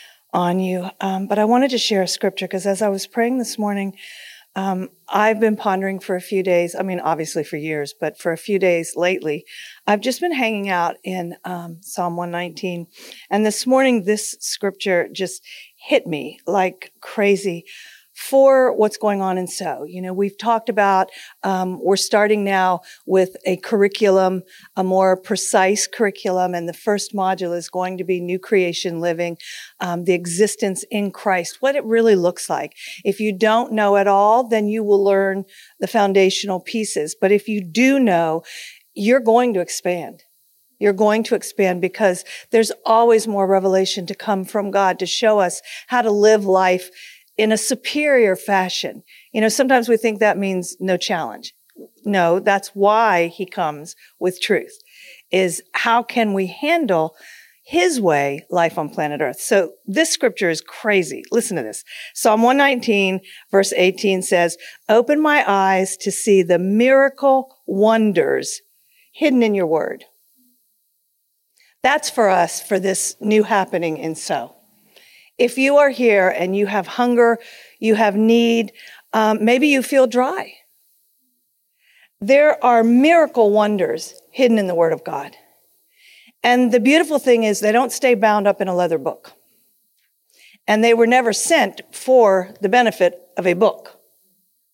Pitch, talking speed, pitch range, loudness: 200 Hz, 160 wpm, 185-235 Hz, -18 LUFS